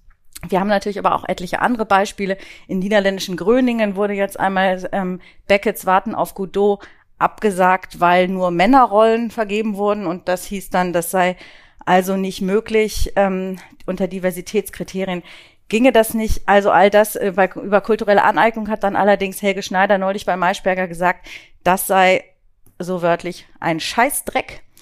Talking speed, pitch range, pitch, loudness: 150 wpm, 180-205 Hz, 190 Hz, -18 LUFS